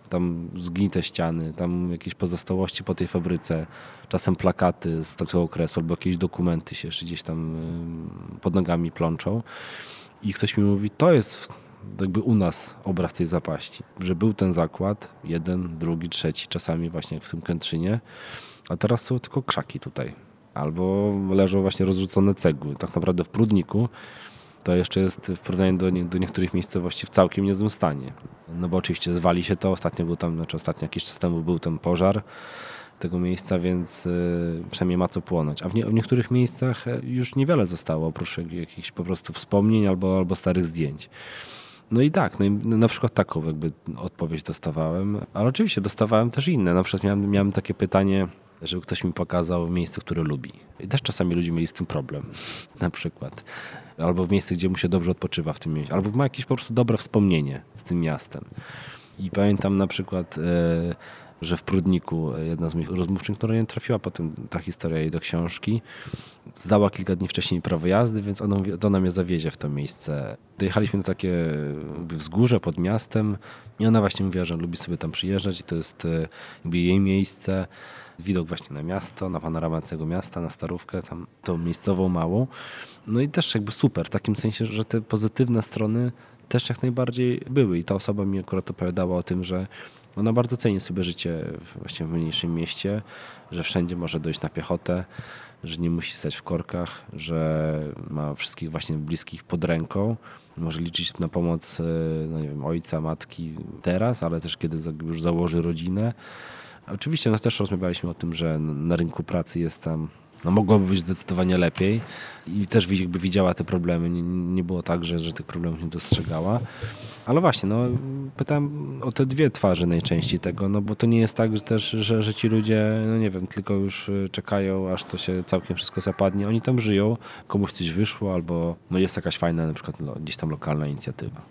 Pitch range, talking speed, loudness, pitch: 85-105 Hz, 185 wpm, -25 LUFS, 90 Hz